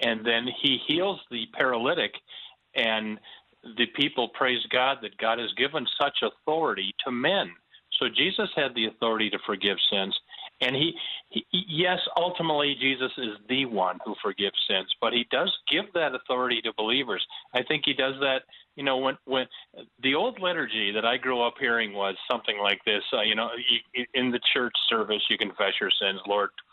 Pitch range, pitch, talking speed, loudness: 115-140 Hz, 125 Hz, 180 wpm, -26 LUFS